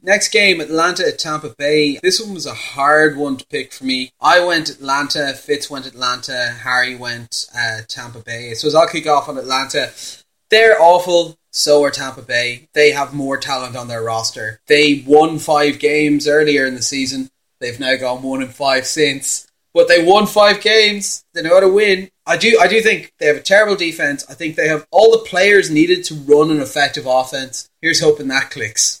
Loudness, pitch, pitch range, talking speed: -14 LUFS, 150 Hz, 130-175 Hz, 205 wpm